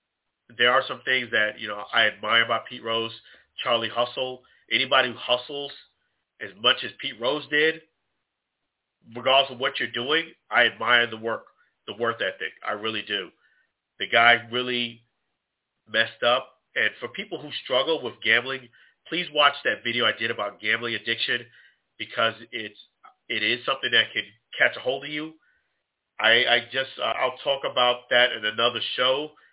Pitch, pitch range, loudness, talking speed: 125 Hz, 115-135 Hz, -23 LUFS, 165 wpm